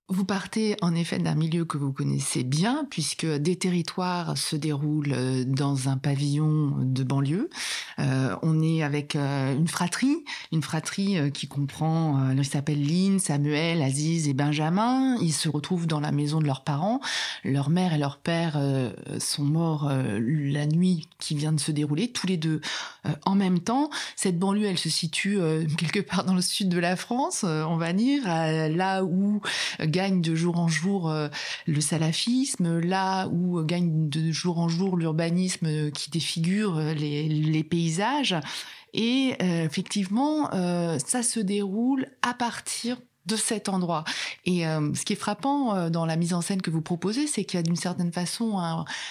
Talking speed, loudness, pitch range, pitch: 165 wpm, -26 LUFS, 150-190 Hz, 170 Hz